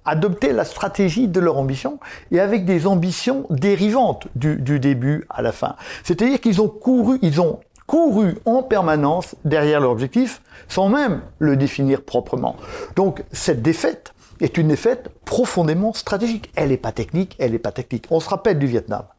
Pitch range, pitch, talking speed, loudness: 140-215 Hz, 175 Hz, 170 wpm, -19 LUFS